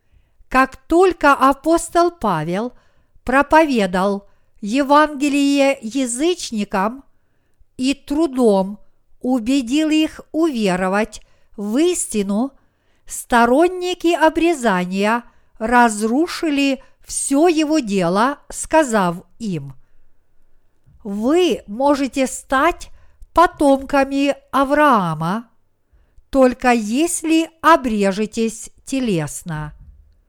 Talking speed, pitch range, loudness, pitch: 60 wpm, 205-305 Hz, -17 LUFS, 260 Hz